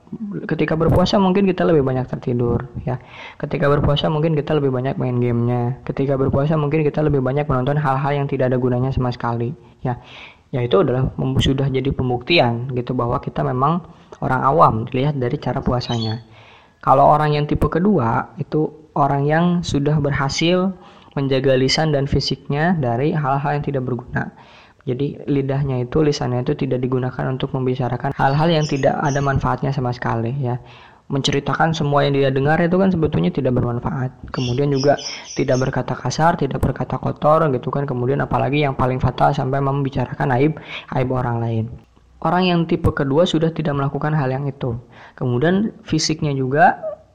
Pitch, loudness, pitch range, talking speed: 140 Hz, -19 LUFS, 125-150 Hz, 160 wpm